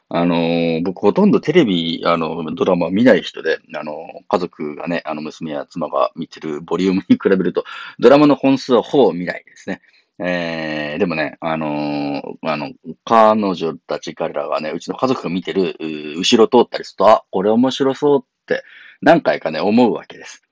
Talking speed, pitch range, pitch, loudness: 345 characters per minute, 80-120 Hz, 85 Hz, -17 LUFS